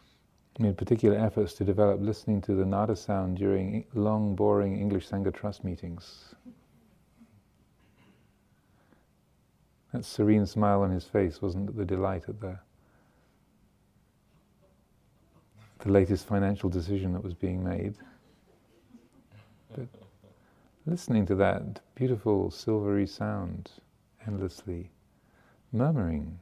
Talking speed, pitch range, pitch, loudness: 100 wpm, 95-105 Hz, 100 Hz, -29 LUFS